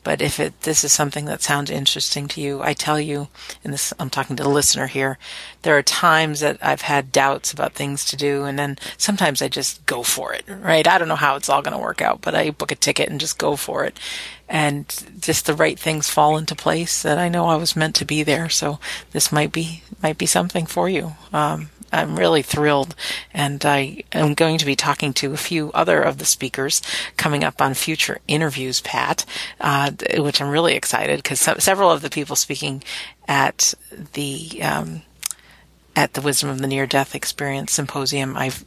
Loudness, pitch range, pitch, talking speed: -19 LUFS, 140-155 Hz, 145 Hz, 210 wpm